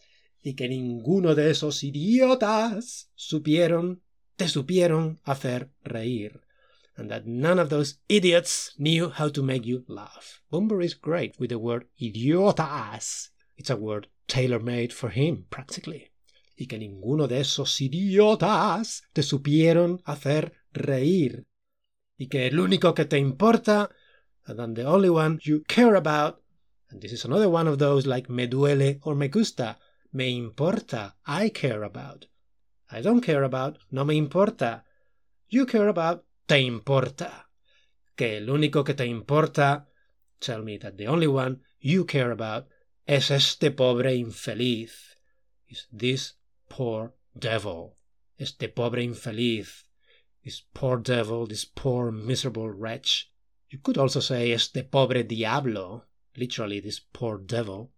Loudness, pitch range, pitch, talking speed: -25 LUFS, 120-160 Hz, 140 Hz, 140 wpm